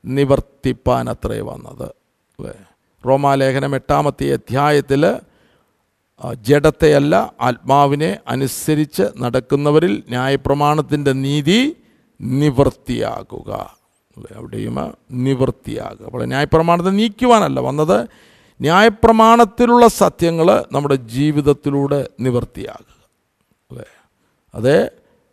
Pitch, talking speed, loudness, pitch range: 140 Hz, 70 wpm, -16 LUFS, 130-160 Hz